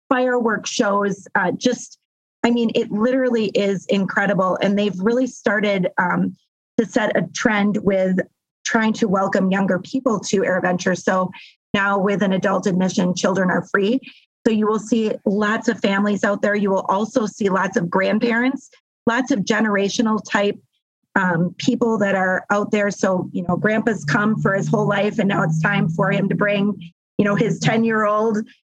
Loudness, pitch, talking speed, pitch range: -19 LUFS, 205 Hz, 170 wpm, 195-225 Hz